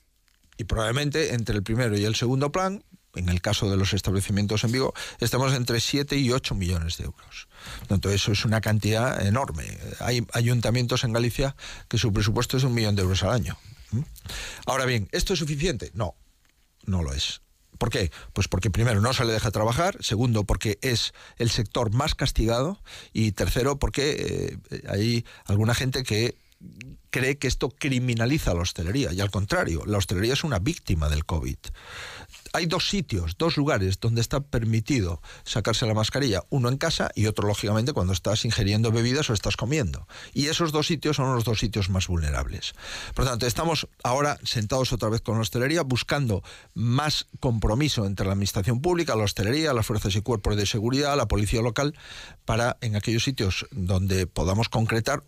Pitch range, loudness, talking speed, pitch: 100-130 Hz, -25 LUFS, 180 wpm, 115 Hz